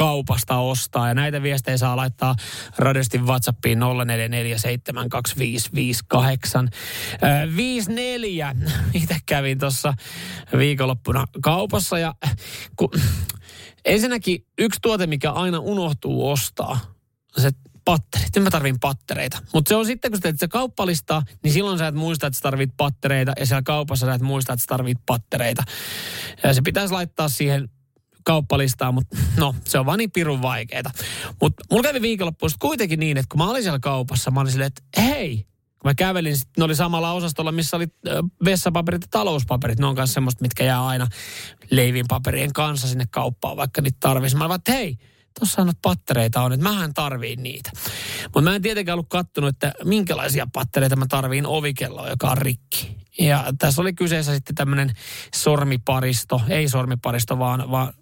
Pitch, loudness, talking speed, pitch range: 135 Hz, -22 LUFS, 160 wpm, 125-165 Hz